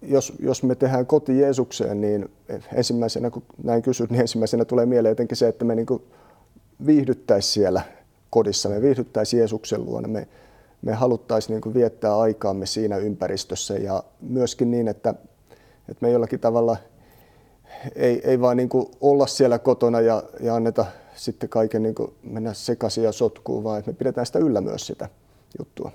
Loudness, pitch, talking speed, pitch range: -22 LUFS, 115 Hz, 155 wpm, 110-125 Hz